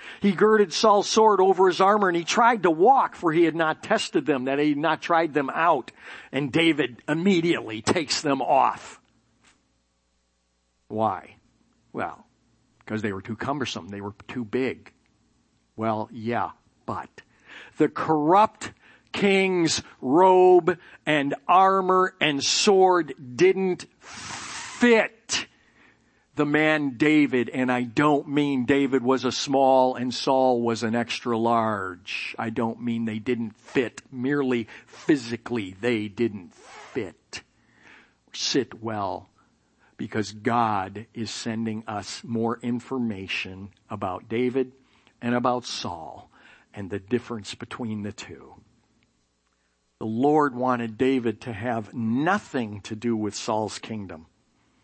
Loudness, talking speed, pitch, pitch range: -24 LUFS, 125 wpm, 125 Hz, 110-150 Hz